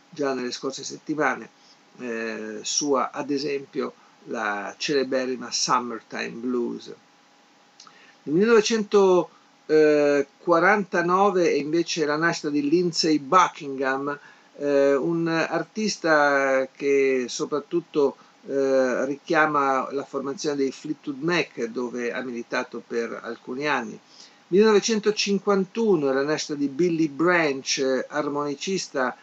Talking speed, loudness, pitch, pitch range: 95 wpm, -23 LUFS, 145 Hz, 135-175 Hz